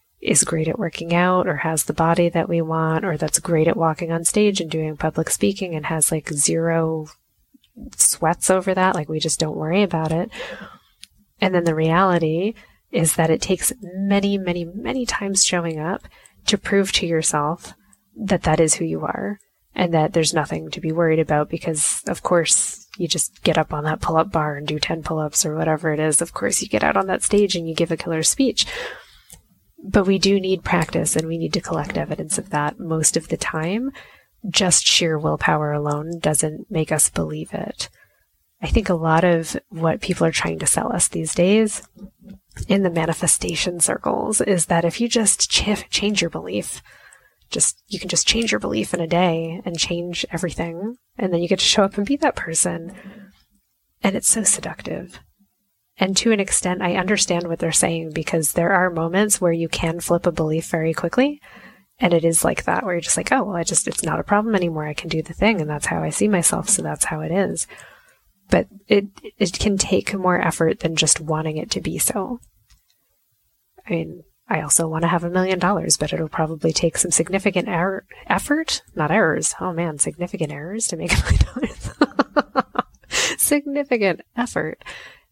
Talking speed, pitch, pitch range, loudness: 200 wpm, 170 Hz, 160-195 Hz, -20 LUFS